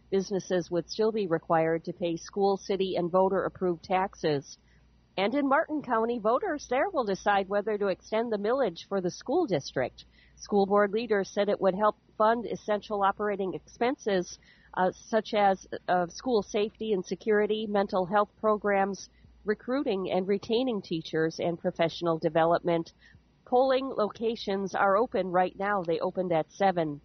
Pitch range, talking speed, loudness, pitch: 180-215 Hz, 155 wpm, -29 LUFS, 195 Hz